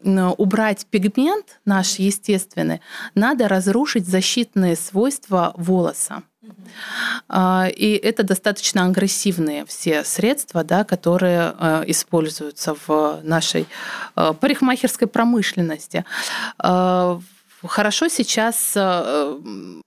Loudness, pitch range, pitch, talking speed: -19 LUFS, 175-220 Hz, 195 Hz, 70 wpm